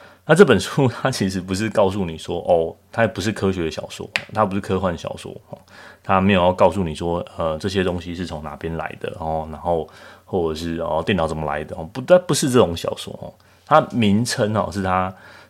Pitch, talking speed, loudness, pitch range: 95 Hz, 300 characters per minute, -20 LUFS, 80-105 Hz